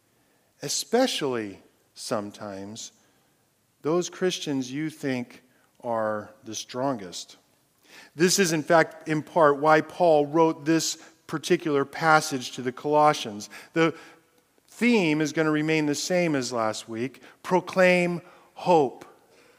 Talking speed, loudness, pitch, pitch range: 115 wpm, -25 LUFS, 155 Hz, 130-170 Hz